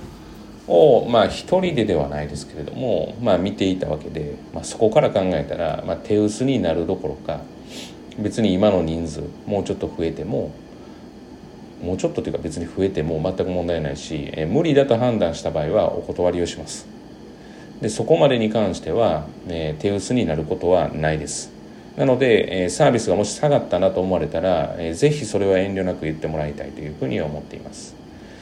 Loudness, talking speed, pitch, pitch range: -21 LUFS, 370 characters per minute, 90 Hz, 80-110 Hz